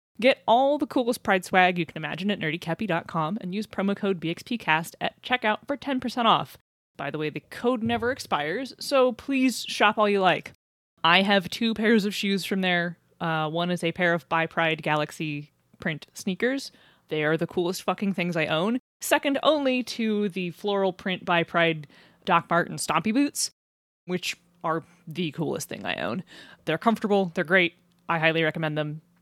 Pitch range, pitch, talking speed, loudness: 165-220 Hz, 180 Hz, 175 wpm, -25 LUFS